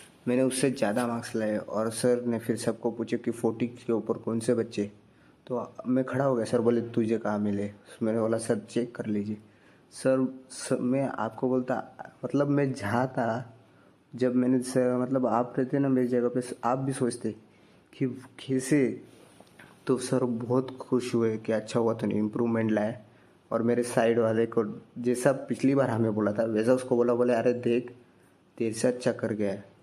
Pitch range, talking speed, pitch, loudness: 110-130 Hz, 185 wpm, 120 Hz, -28 LUFS